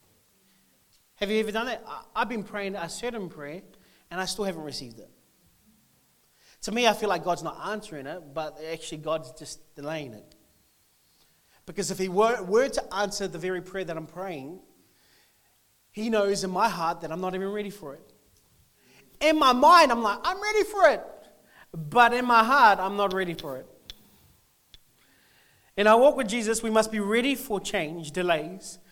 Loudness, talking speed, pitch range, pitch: -25 LUFS, 180 wpm, 160-220 Hz, 195 Hz